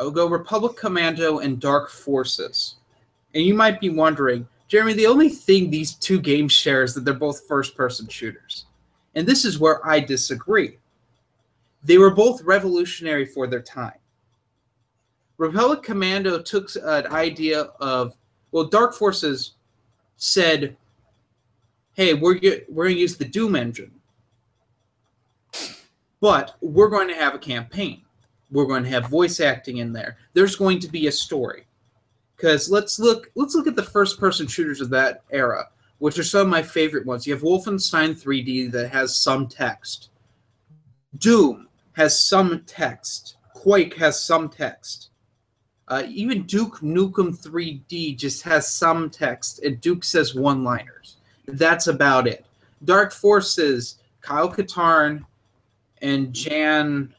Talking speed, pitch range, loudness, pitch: 145 wpm, 125-175 Hz, -20 LUFS, 145 Hz